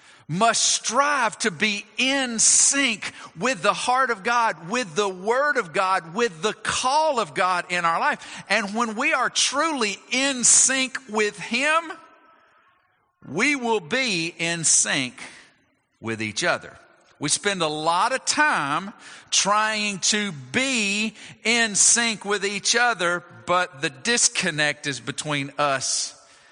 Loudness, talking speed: -21 LUFS, 140 wpm